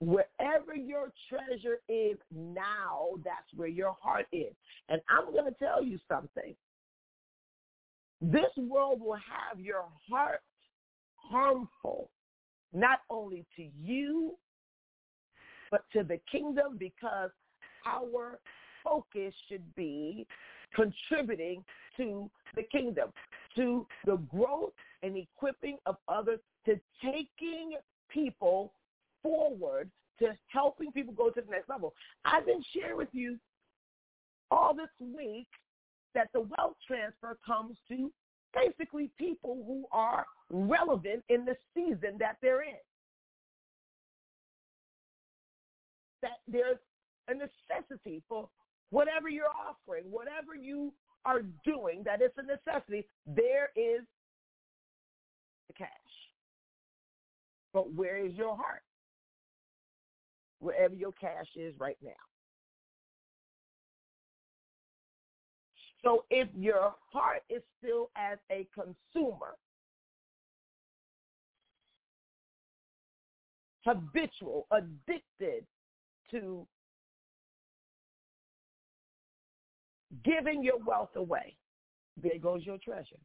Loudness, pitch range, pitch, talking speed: -34 LUFS, 200-290 Hz, 245 Hz, 100 wpm